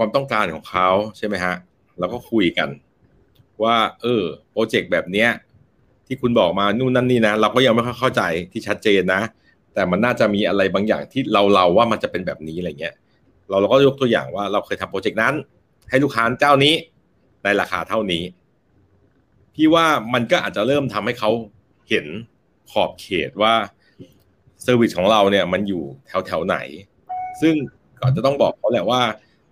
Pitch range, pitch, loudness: 100-135 Hz, 115 Hz, -19 LUFS